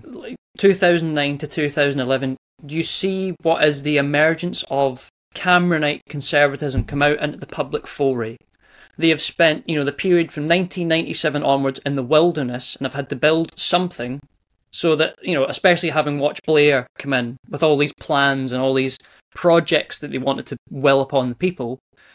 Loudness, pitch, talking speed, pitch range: -19 LUFS, 145 Hz, 190 wpm, 135-165 Hz